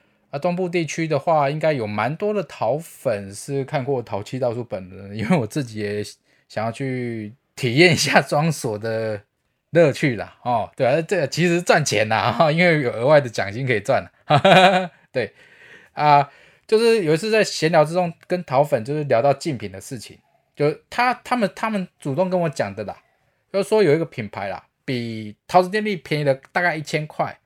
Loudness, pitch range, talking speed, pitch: -20 LUFS, 120-175 Hz, 280 characters per minute, 145 Hz